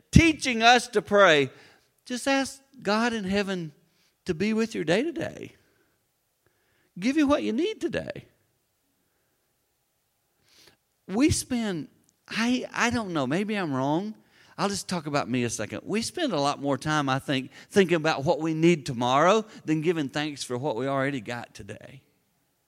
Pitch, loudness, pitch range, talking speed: 180 Hz, -26 LUFS, 140-225 Hz, 160 wpm